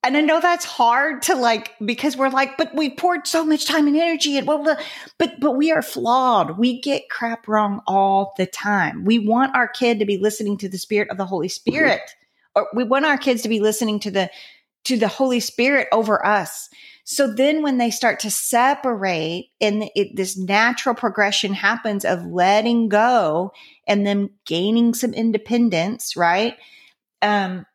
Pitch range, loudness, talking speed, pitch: 210-275 Hz, -19 LUFS, 185 wpm, 235 Hz